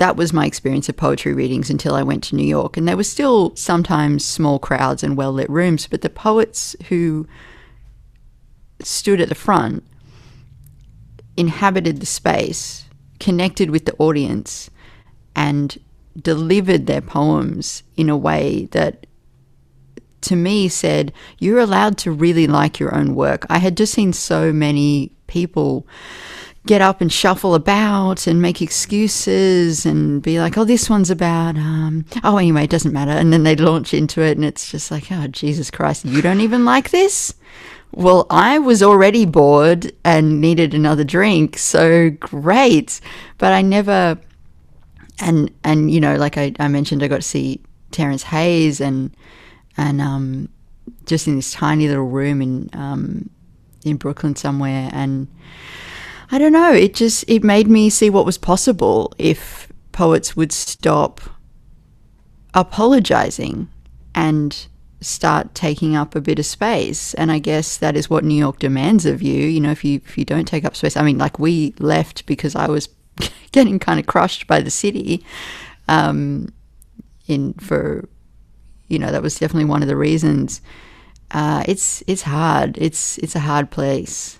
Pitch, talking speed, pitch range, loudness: 155 Hz, 165 wpm, 140-180 Hz, -16 LUFS